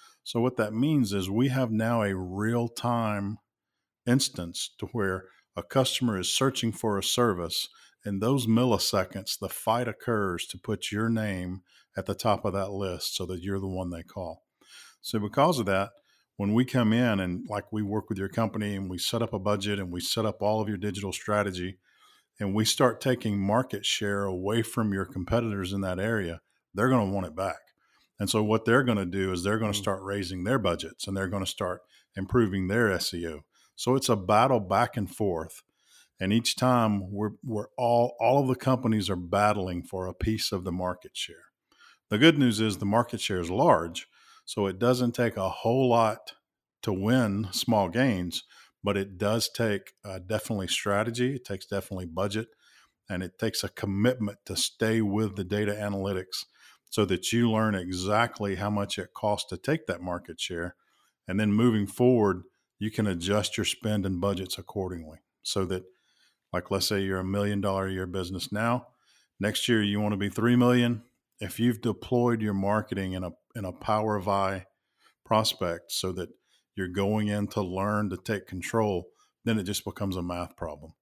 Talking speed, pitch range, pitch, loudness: 195 wpm, 95-115 Hz, 105 Hz, -28 LUFS